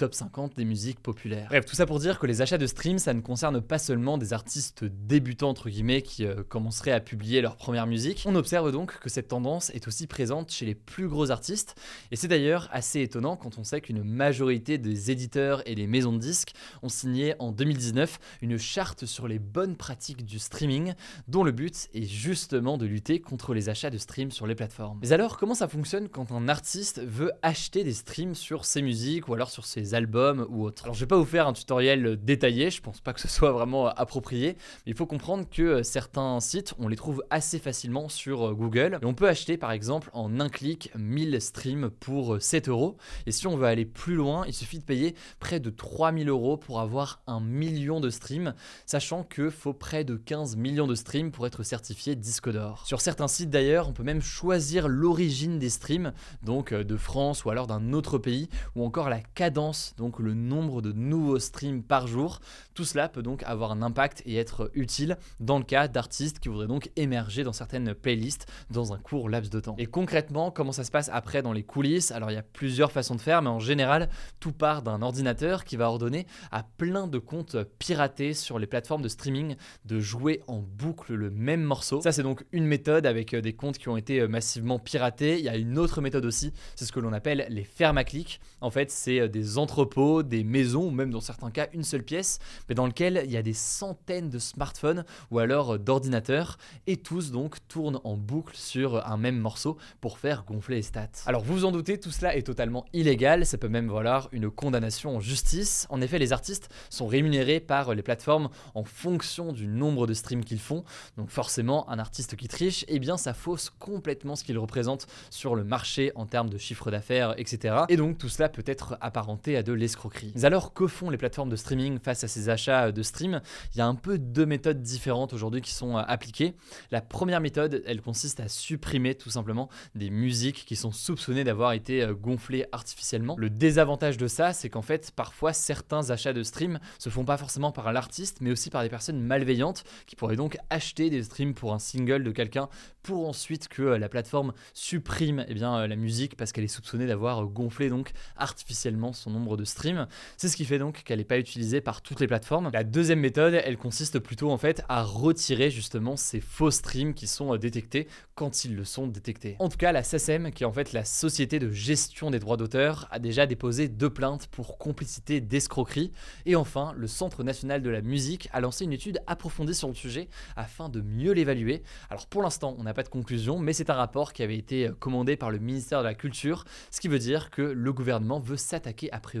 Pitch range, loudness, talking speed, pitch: 115-150 Hz, -29 LUFS, 215 wpm, 135 Hz